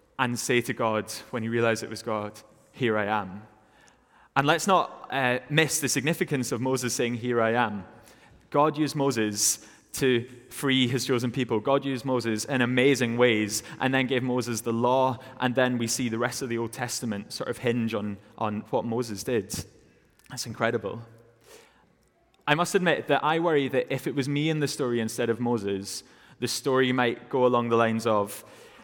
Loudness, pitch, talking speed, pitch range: -26 LUFS, 120 Hz, 190 wpm, 115-130 Hz